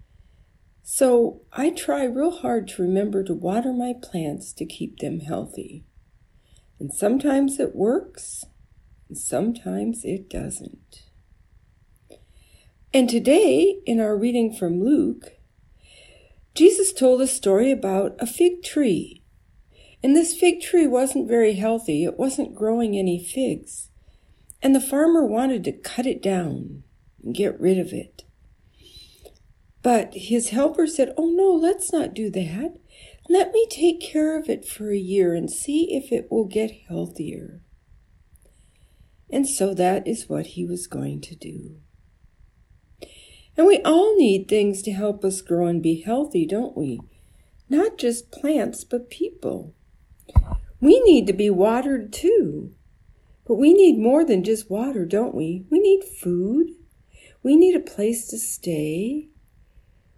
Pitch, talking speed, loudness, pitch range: 235 Hz, 140 wpm, -21 LUFS, 190-310 Hz